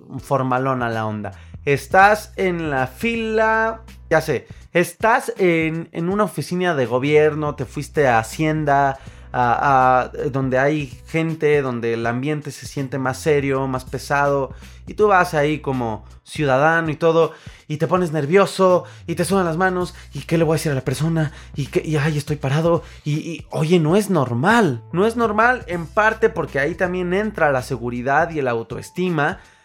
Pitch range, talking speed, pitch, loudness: 130-175 Hz, 175 wpm, 150 Hz, -19 LUFS